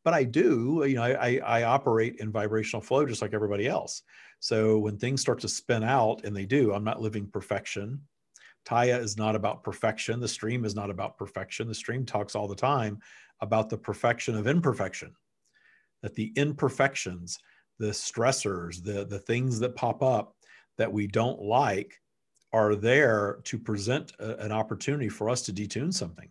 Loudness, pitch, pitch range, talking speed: -28 LUFS, 110 Hz, 105-125 Hz, 180 wpm